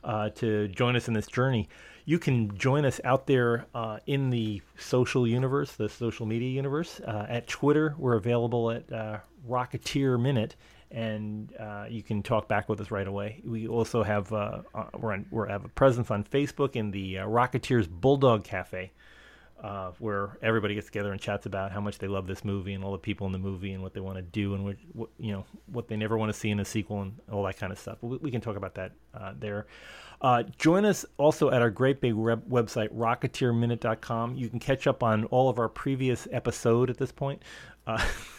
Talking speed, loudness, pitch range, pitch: 215 wpm, -29 LUFS, 105-125 Hz, 115 Hz